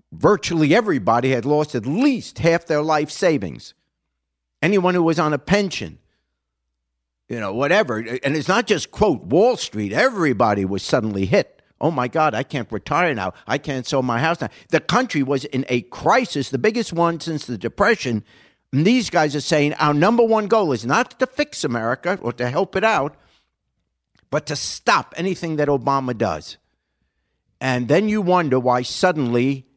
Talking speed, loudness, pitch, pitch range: 175 wpm, -20 LUFS, 140 Hz, 120-170 Hz